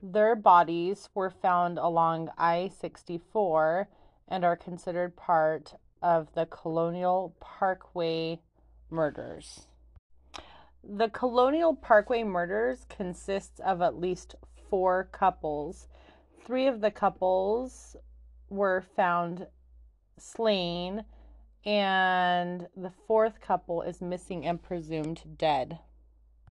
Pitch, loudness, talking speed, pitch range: 180 Hz, -29 LUFS, 95 wpm, 165-195 Hz